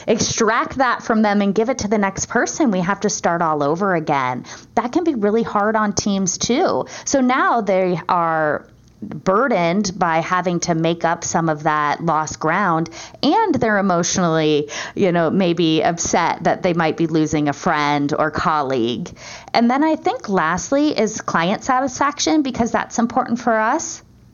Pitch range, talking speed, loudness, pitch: 165-235 Hz, 175 wpm, -18 LUFS, 195 Hz